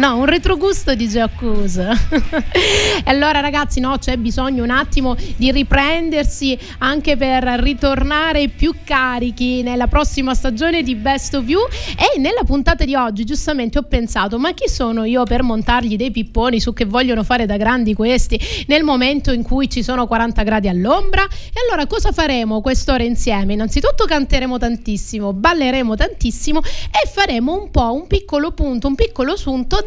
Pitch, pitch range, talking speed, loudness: 260 Hz, 240-295 Hz, 165 wpm, -17 LUFS